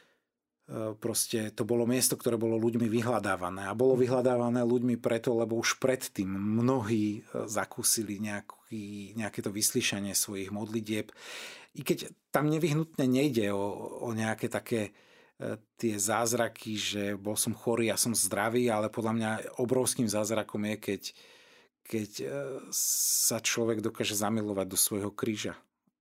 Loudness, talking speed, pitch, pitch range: -30 LUFS, 130 wpm, 115 Hz, 105-125 Hz